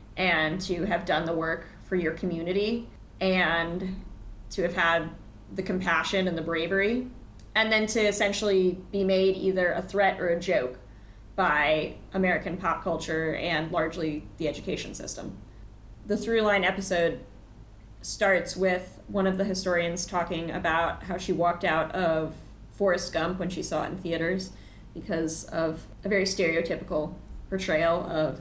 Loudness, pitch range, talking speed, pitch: -27 LUFS, 160-190 Hz, 150 wpm, 175 Hz